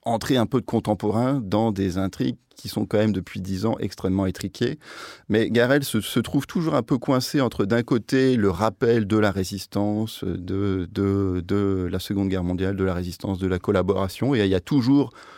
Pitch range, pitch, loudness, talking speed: 95-120 Hz, 105 Hz, -23 LUFS, 205 wpm